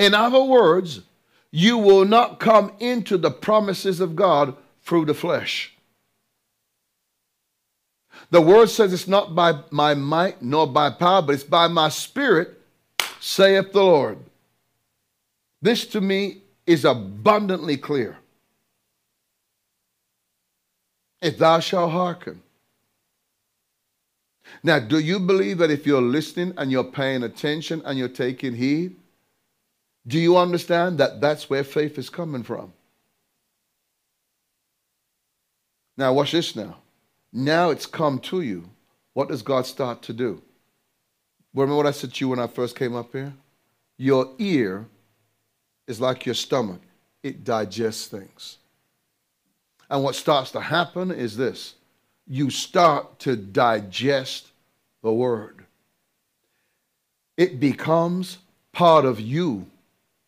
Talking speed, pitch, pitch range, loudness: 125 wpm, 150 Hz, 130-180 Hz, -21 LUFS